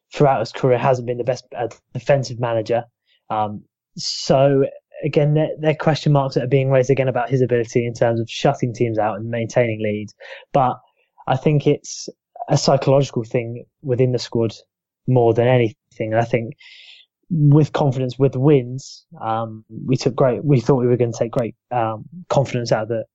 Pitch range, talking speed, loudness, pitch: 120-145 Hz, 180 wpm, -19 LUFS, 130 Hz